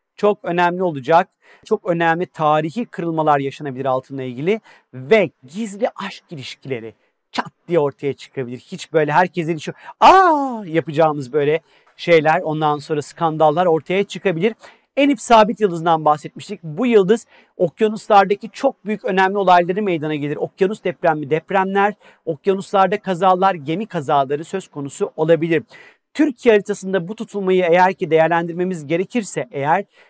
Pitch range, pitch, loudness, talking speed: 160-205 Hz, 180 Hz, -18 LUFS, 130 wpm